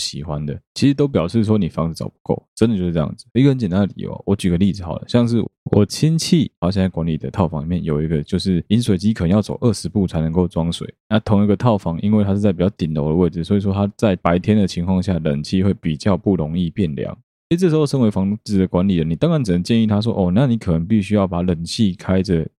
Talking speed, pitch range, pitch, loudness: 390 characters per minute, 85-105 Hz, 95 Hz, -18 LUFS